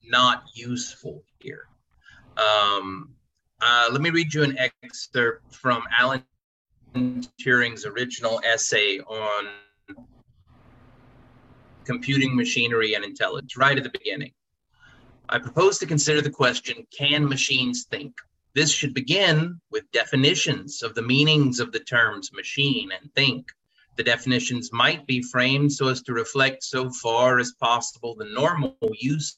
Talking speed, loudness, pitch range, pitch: 130 wpm, -22 LUFS, 120-145 Hz, 125 Hz